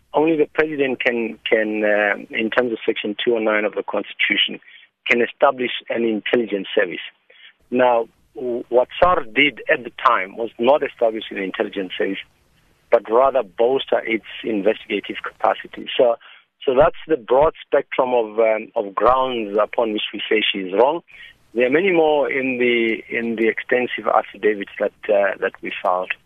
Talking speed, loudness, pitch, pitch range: 160 wpm, -19 LUFS, 115 Hz, 105-130 Hz